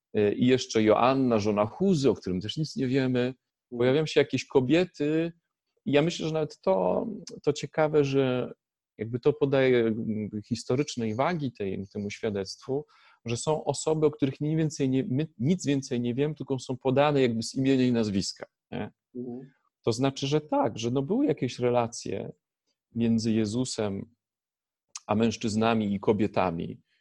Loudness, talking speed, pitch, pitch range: -27 LUFS, 150 wpm, 130 Hz, 115-145 Hz